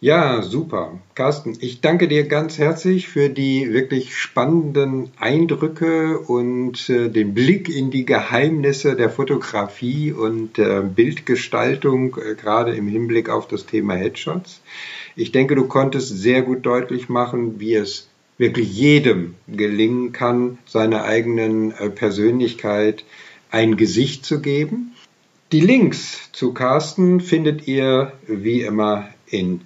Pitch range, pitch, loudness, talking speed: 110-150 Hz, 125 Hz, -19 LUFS, 130 wpm